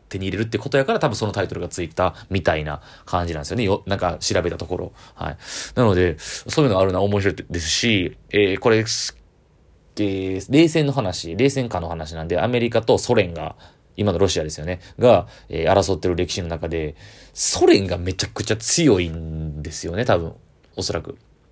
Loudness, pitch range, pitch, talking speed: -21 LUFS, 85-115 Hz, 95 Hz, 380 characters per minute